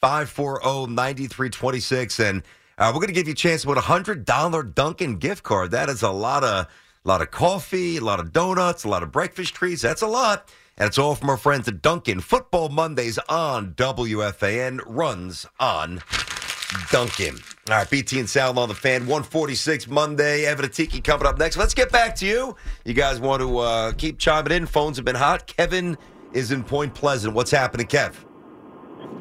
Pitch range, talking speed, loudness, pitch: 125-165 Hz, 195 wpm, -22 LUFS, 140 Hz